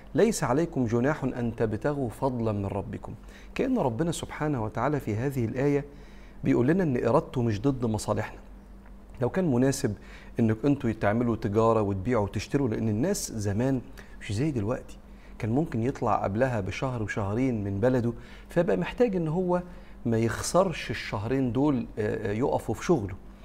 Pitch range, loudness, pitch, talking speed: 110-140 Hz, -28 LUFS, 120 Hz, 145 wpm